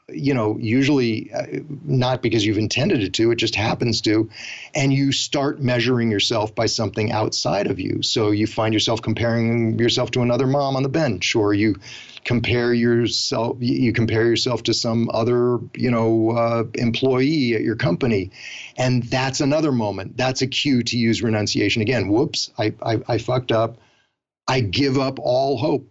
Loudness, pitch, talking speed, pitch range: -20 LUFS, 120 Hz, 170 wpm, 115-130 Hz